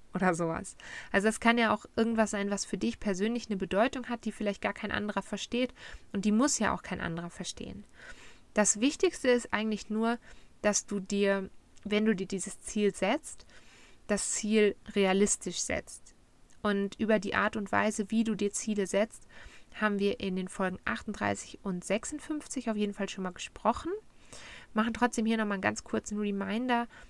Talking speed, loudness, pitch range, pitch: 180 wpm, -31 LUFS, 200-230 Hz, 210 Hz